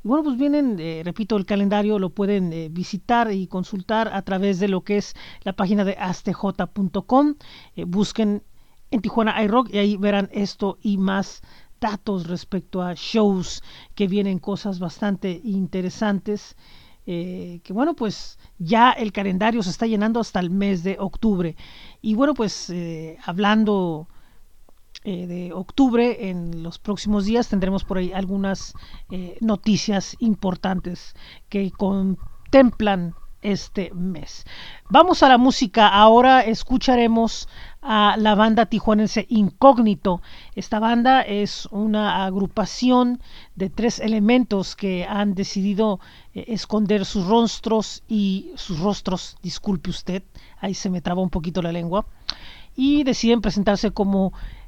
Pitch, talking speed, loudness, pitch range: 205 Hz, 135 wpm, -21 LUFS, 190-220 Hz